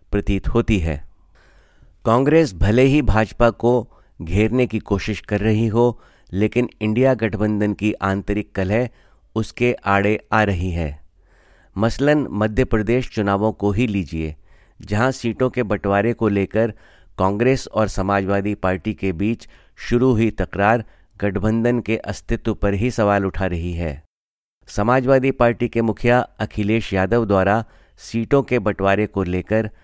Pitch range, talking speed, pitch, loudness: 95-120 Hz, 135 wpm, 105 Hz, -20 LUFS